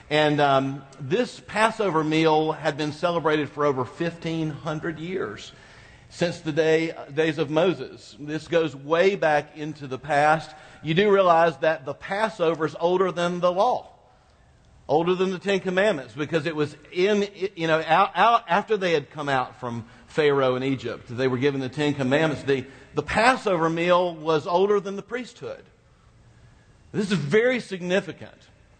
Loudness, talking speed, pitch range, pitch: -23 LUFS, 155 wpm, 145-180 Hz, 160 Hz